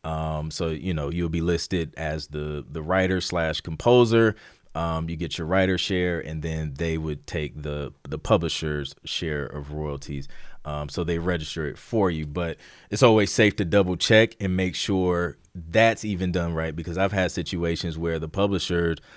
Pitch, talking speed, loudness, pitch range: 85 Hz, 180 wpm, -25 LUFS, 80-95 Hz